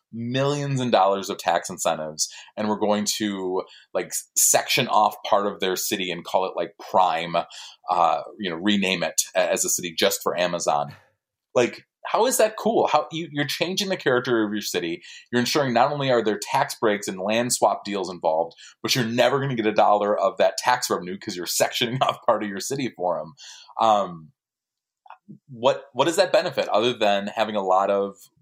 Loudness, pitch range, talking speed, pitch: -23 LUFS, 100-130 Hz, 200 wpm, 110 Hz